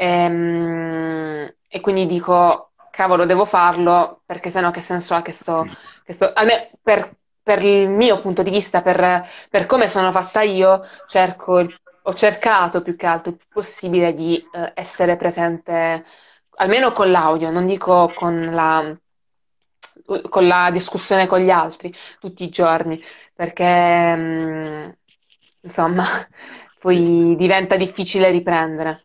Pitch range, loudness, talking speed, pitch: 170-190 Hz, -17 LUFS, 130 wpm, 180 Hz